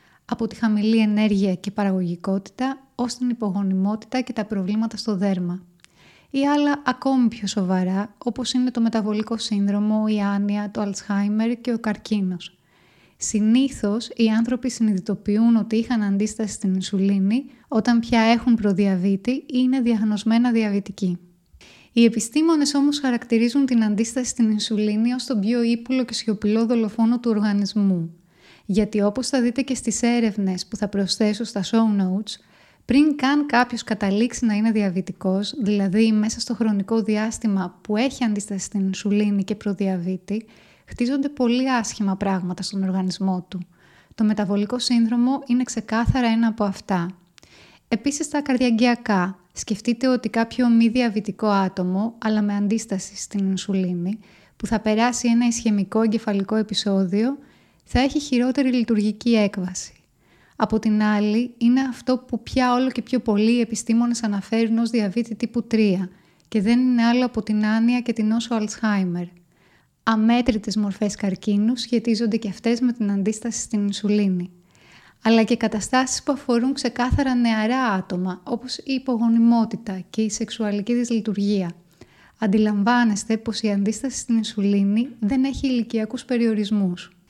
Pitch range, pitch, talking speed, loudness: 200-240 Hz, 220 Hz, 140 wpm, -22 LUFS